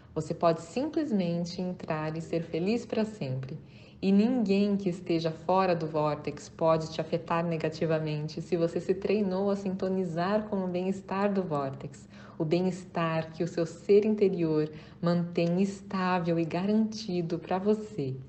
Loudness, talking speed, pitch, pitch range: -30 LUFS, 145 wpm, 175 Hz, 165-195 Hz